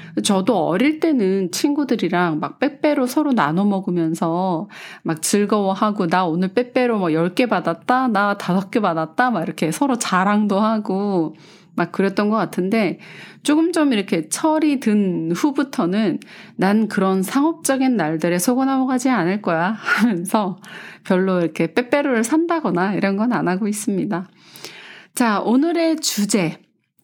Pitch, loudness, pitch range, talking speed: 205 Hz, -19 LUFS, 180-250 Hz, 285 characters per minute